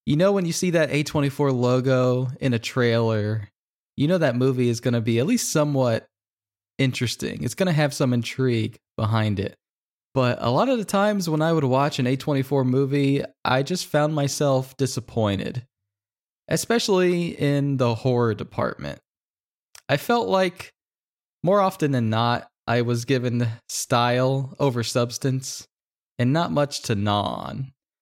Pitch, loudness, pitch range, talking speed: 130 Hz, -23 LUFS, 120-145 Hz, 155 wpm